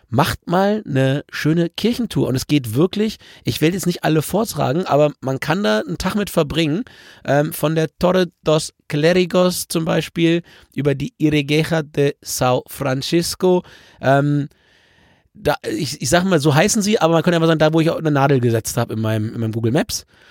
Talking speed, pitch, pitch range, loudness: 190 wpm, 155 Hz, 140-175 Hz, -18 LUFS